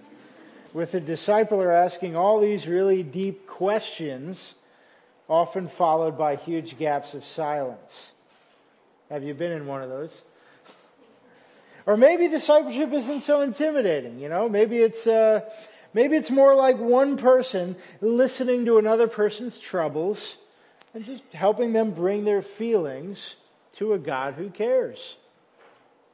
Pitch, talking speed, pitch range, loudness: 210 Hz, 135 wpm, 175-255 Hz, -23 LUFS